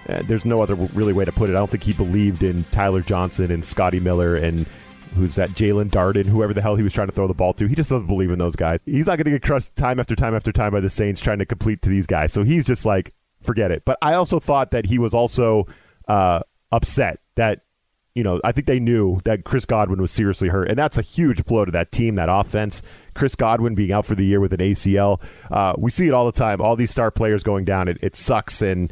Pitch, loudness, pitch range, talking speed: 105 Hz, -20 LUFS, 95-115 Hz, 265 wpm